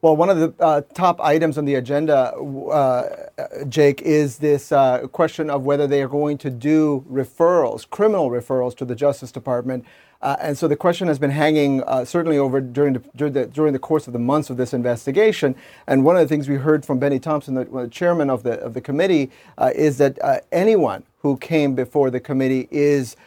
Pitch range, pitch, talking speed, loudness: 135-155 Hz, 145 Hz, 210 wpm, -19 LUFS